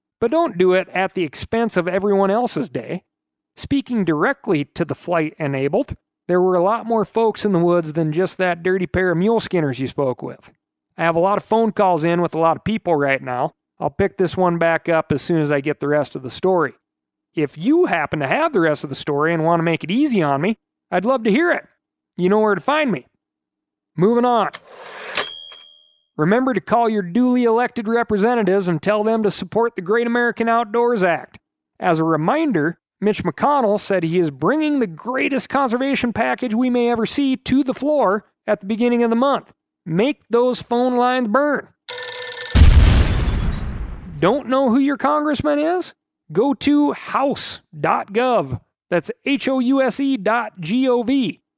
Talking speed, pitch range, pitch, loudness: 195 wpm, 175-250 Hz, 215 Hz, -19 LUFS